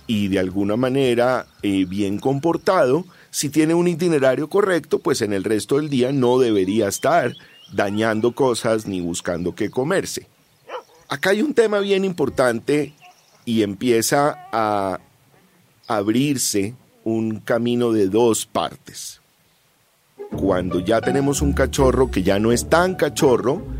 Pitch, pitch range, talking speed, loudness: 125 Hz, 105-155 Hz, 135 wpm, -20 LUFS